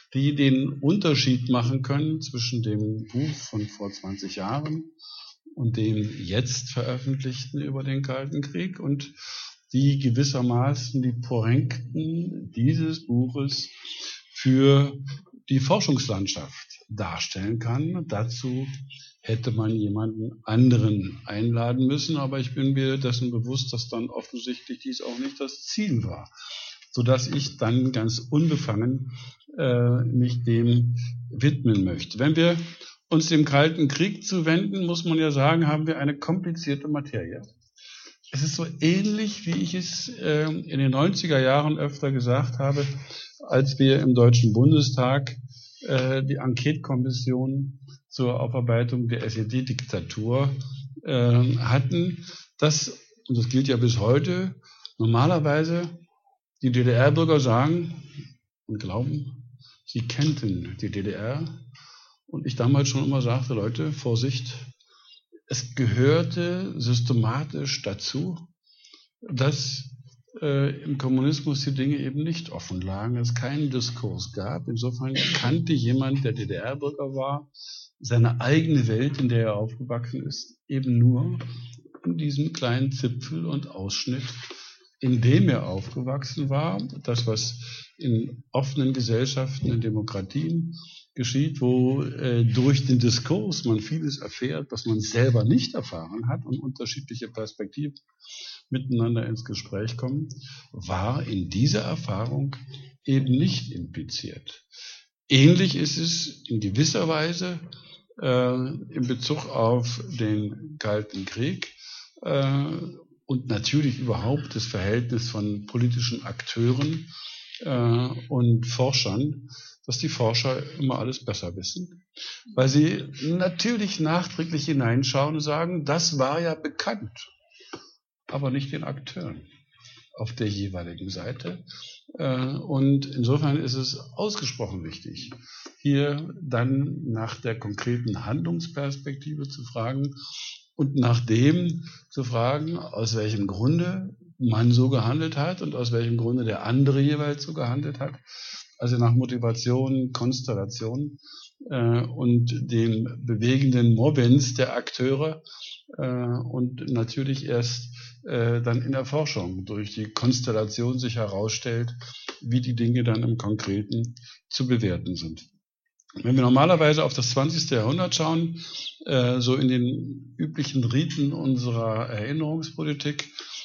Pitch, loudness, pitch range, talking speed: 130 Hz, -25 LUFS, 120-145 Hz, 120 wpm